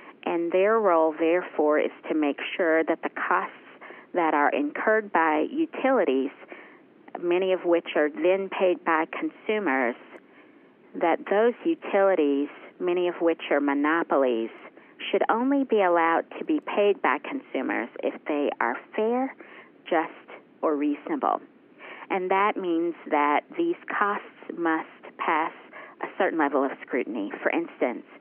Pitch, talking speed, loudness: 195 Hz, 135 wpm, -25 LUFS